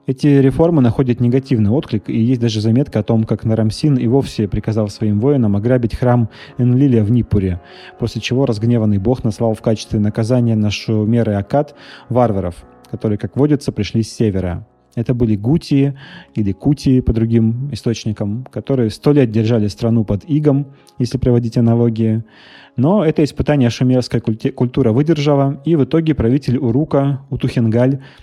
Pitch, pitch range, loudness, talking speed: 120 Hz, 110-135 Hz, -16 LUFS, 155 wpm